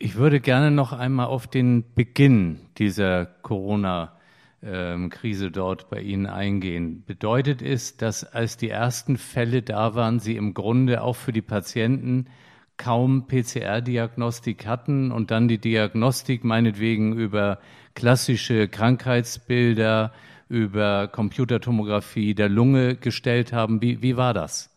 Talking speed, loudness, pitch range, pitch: 125 wpm, -23 LUFS, 105-125 Hz, 115 Hz